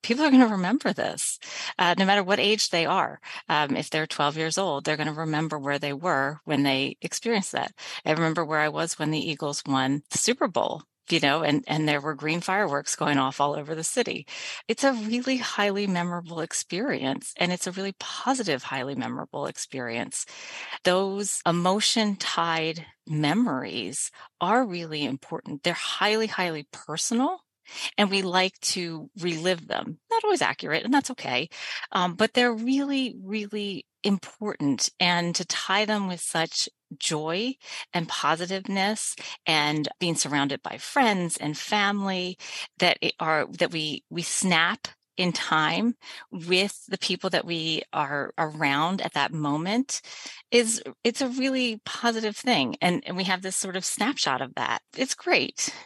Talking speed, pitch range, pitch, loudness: 165 wpm, 155-215 Hz, 180 Hz, -26 LUFS